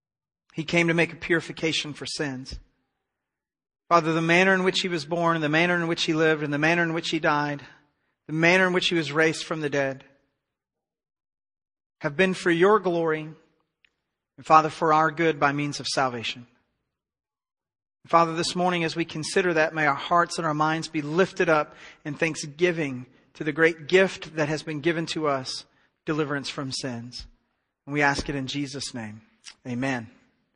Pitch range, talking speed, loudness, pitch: 145-170 Hz, 180 wpm, -24 LUFS, 155 Hz